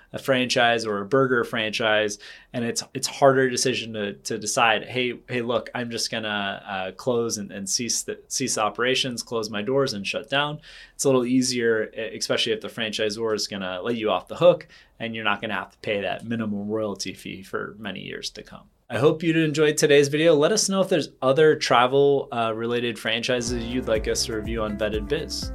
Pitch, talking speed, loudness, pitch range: 115 Hz, 210 wpm, -23 LUFS, 110-135 Hz